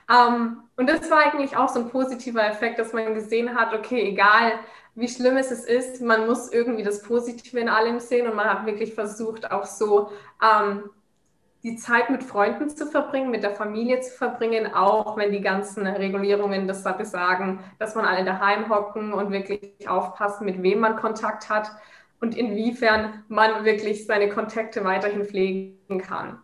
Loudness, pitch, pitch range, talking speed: -23 LUFS, 220 Hz, 205-235 Hz, 170 wpm